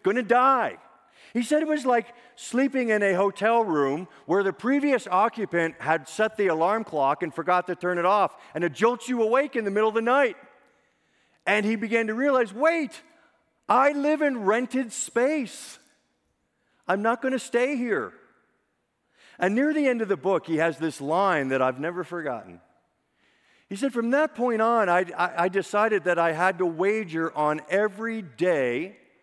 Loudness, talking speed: -24 LUFS, 185 wpm